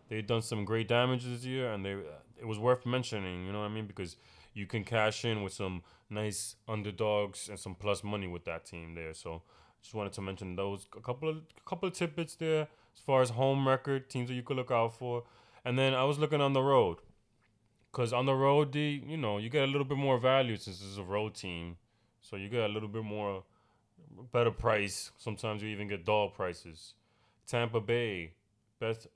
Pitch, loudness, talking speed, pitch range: 110 Hz, -34 LUFS, 220 wpm, 100-125 Hz